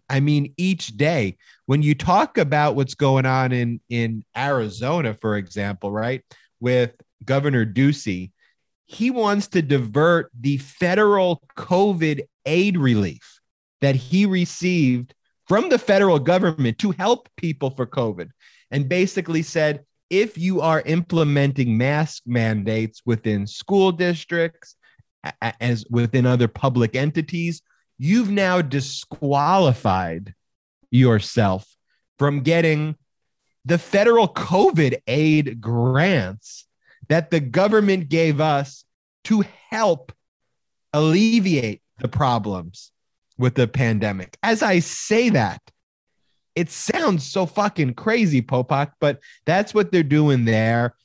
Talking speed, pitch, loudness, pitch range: 115 wpm, 145 Hz, -20 LUFS, 120-175 Hz